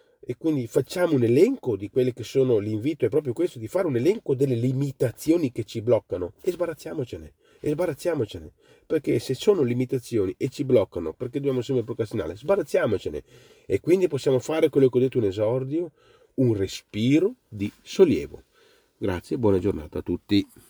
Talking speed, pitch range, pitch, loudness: 170 wpm, 115-160 Hz, 130 Hz, -25 LUFS